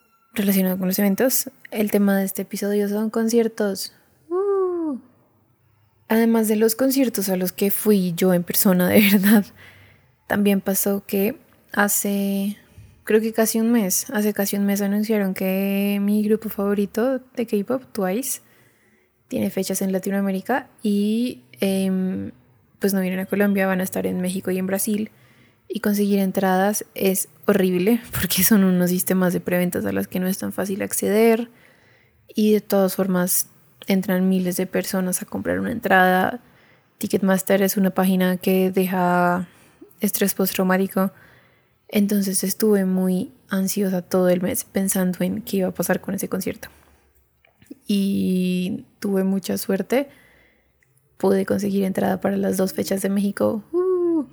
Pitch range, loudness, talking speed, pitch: 185-210 Hz, -21 LUFS, 145 wpm, 195 Hz